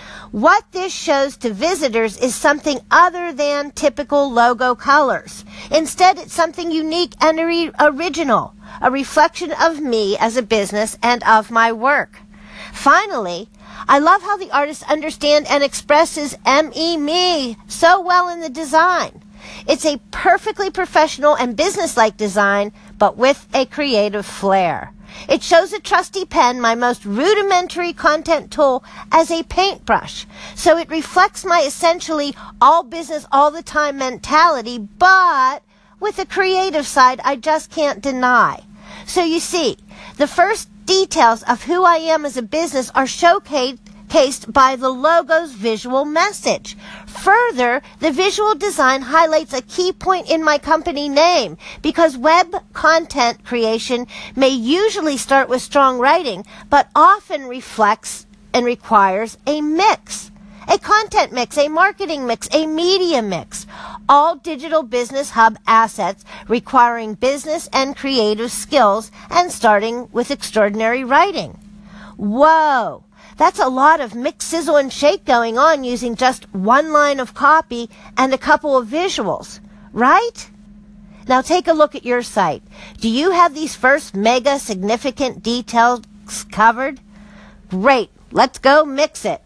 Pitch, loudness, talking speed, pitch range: 280 Hz, -16 LUFS, 140 wpm, 230-325 Hz